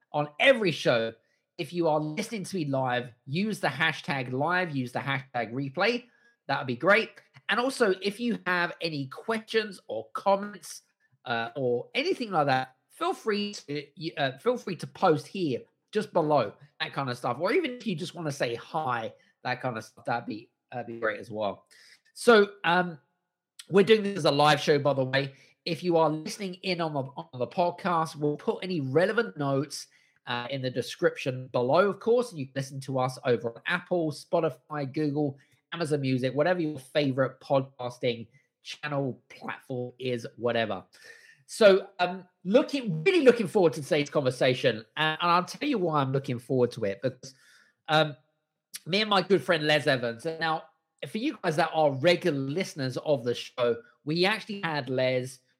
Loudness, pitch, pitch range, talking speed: -28 LUFS, 155 Hz, 135-185 Hz, 180 wpm